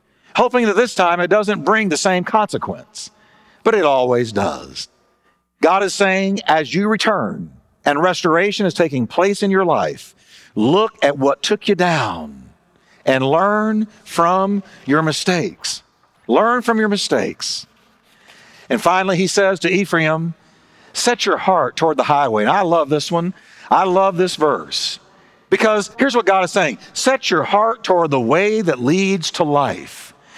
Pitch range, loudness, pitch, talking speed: 165-210 Hz, -17 LUFS, 190 Hz, 160 wpm